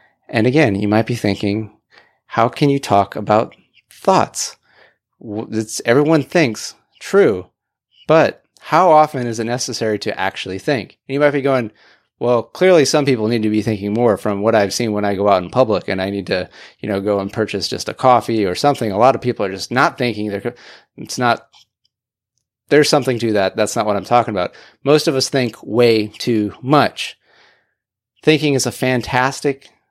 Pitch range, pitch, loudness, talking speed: 105-130 Hz, 115 Hz, -17 LUFS, 190 wpm